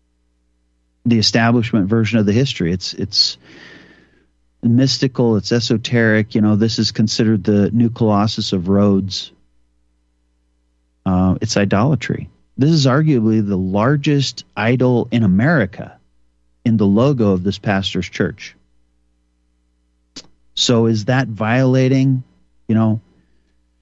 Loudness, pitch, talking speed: -16 LUFS, 105 Hz, 115 wpm